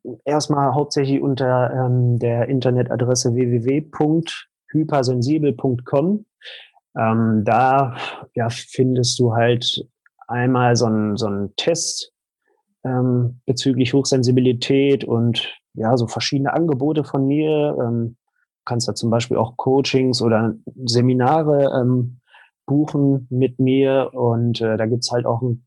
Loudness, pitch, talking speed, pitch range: -19 LUFS, 125 Hz, 115 wpm, 120-140 Hz